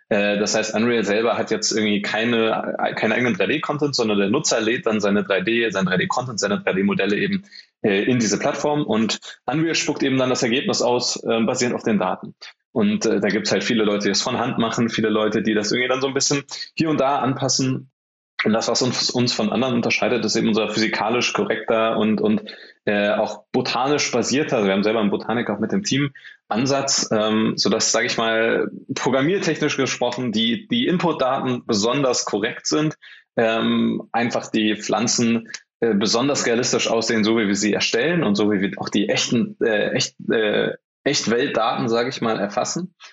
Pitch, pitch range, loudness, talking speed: 115 Hz, 110-135 Hz, -20 LUFS, 185 wpm